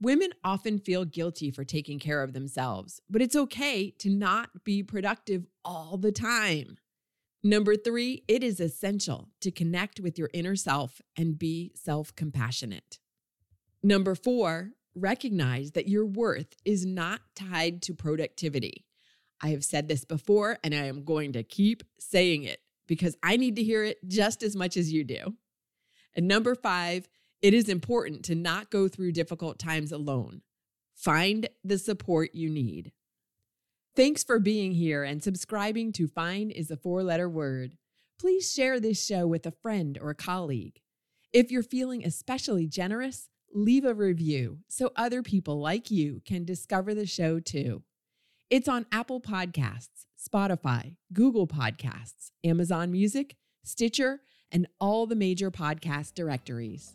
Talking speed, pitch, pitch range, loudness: 155 wpm, 180 Hz, 155-210 Hz, -29 LUFS